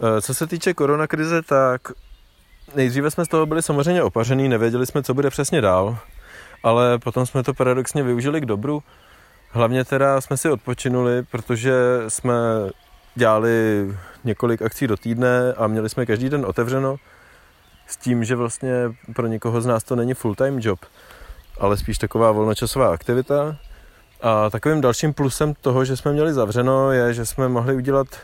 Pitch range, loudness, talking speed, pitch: 115-135 Hz, -20 LUFS, 160 wpm, 125 Hz